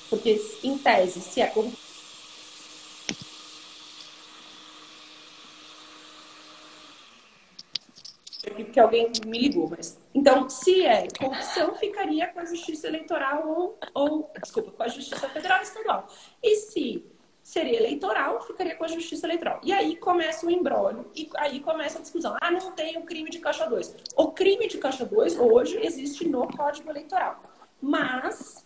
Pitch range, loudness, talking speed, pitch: 270-355 Hz, -26 LUFS, 140 wpm, 320 Hz